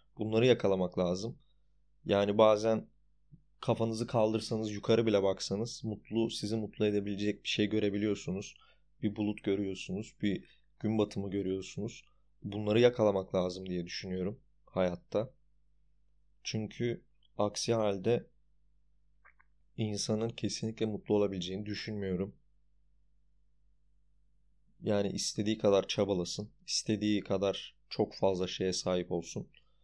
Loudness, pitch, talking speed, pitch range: -33 LUFS, 105 Hz, 100 wpm, 95-110 Hz